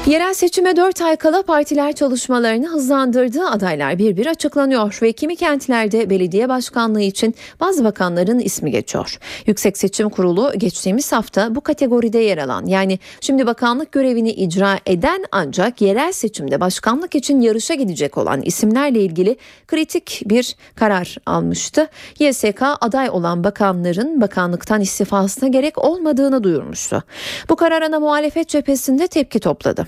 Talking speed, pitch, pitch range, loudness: 135 wpm, 240 Hz, 200-295 Hz, -17 LUFS